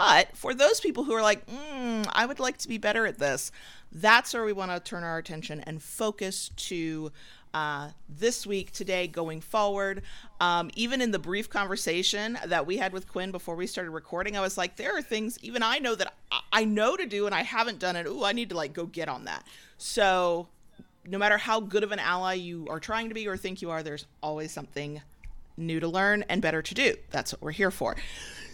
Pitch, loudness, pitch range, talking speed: 190 Hz, -29 LUFS, 165-220 Hz, 225 wpm